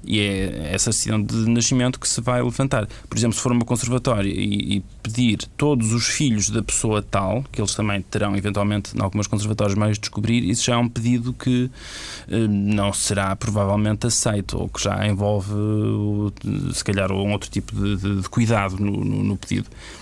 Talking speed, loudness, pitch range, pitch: 190 wpm, -22 LUFS, 100-120 Hz, 105 Hz